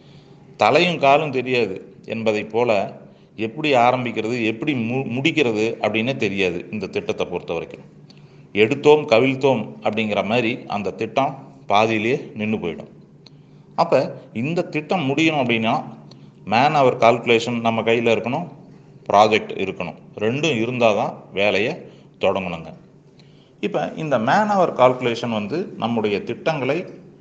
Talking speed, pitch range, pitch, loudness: 110 wpm, 110-135 Hz, 115 Hz, -20 LUFS